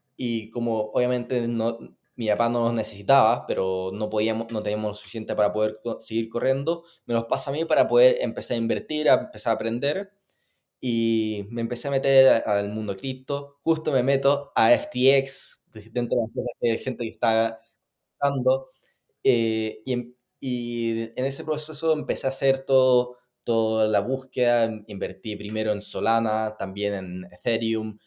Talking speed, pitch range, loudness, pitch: 165 wpm, 110-130 Hz, -25 LUFS, 115 Hz